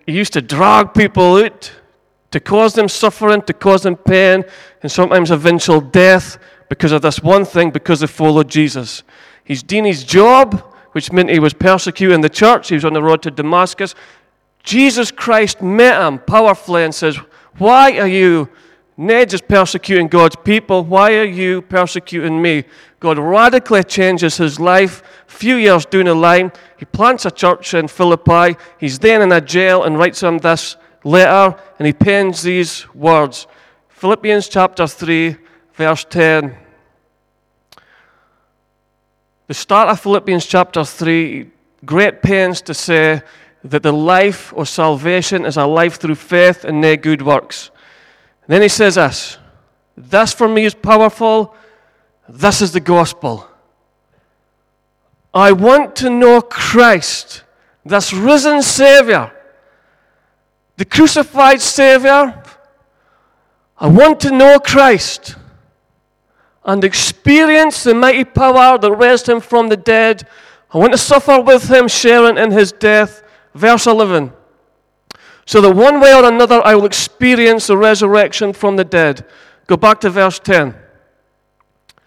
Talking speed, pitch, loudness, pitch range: 145 wpm, 185 Hz, -10 LUFS, 165-220 Hz